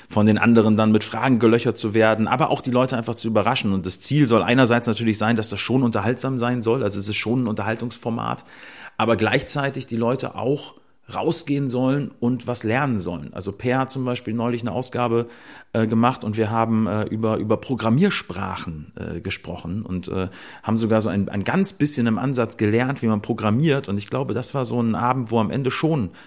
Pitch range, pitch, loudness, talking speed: 110-125 Hz, 115 Hz, -22 LUFS, 210 wpm